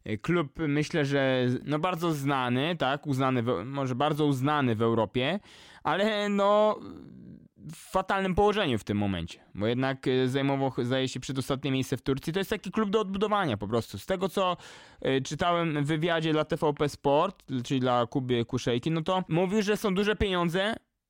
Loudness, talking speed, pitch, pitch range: -28 LUFS, 170 wpm, 145 Hz, 130-185 Hz